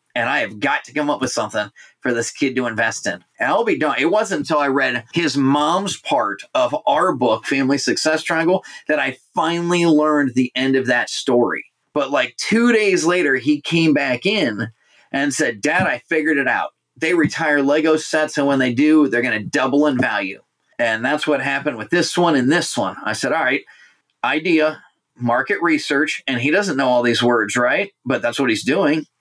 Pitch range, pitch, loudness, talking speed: 130-160 Hz, 145 Hz, -18 LUFS, 210 wpm